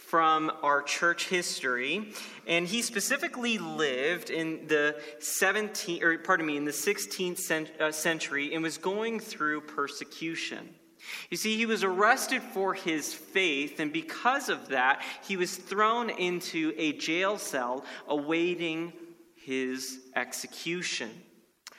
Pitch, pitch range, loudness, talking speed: 170 Hz, 155-200 Hz, -29 LUFS, 125 wpm